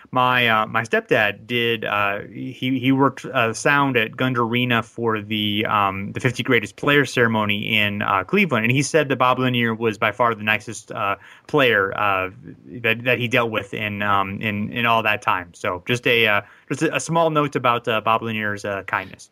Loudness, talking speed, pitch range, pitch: -20 LUFS, 200 wpm, 110-130 Hz, 115 Hz